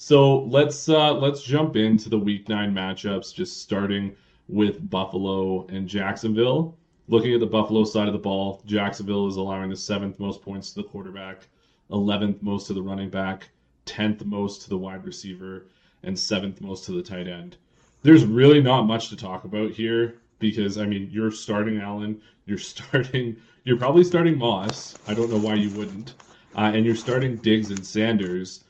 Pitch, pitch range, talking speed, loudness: 105 Hz, 100-115 Hz, 180 wpm, -23 LUFS